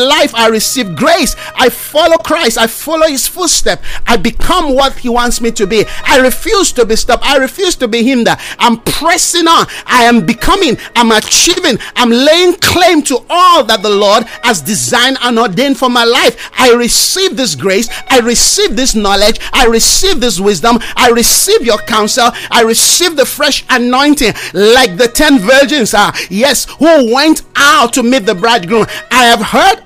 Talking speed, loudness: 180 wpm, -8 LUFS